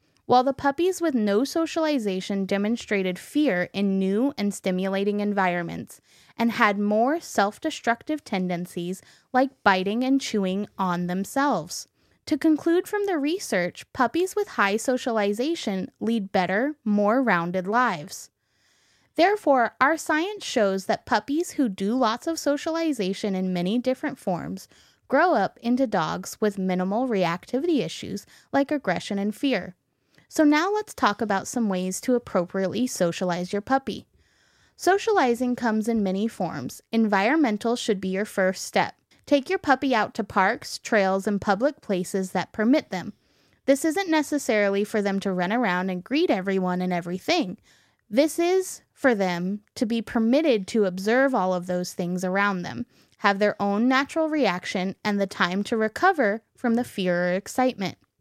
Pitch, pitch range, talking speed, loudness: 220 Hz, 190-275 Hz, 150 wpm, -24 LUFS